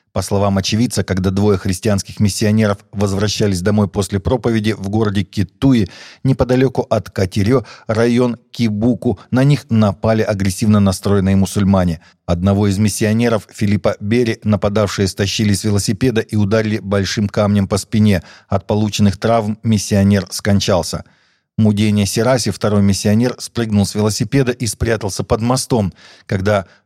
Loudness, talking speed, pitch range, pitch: -16 LUFS, 125 wpm, 100-115 Hz, 105 Hz